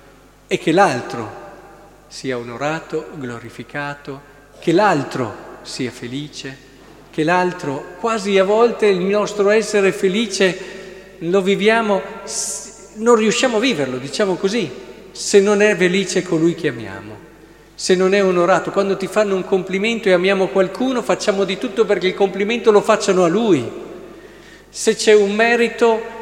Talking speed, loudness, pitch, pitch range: 135 wpm, -17 LUFS, 195 Hz, 165-210 Hz